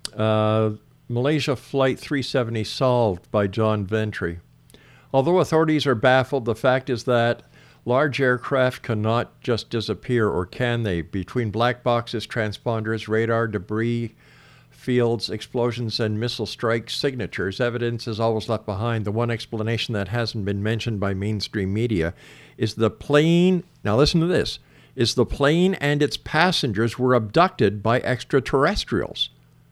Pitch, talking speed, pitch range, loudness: 120 Hz, 135 wpm, 110-130 Hz, -22 LUFS